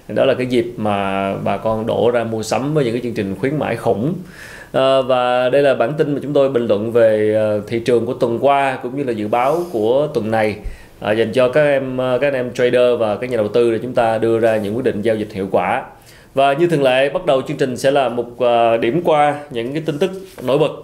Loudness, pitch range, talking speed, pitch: -17 LUFS, 110-140 Hz, 255 wpm, 120 Hz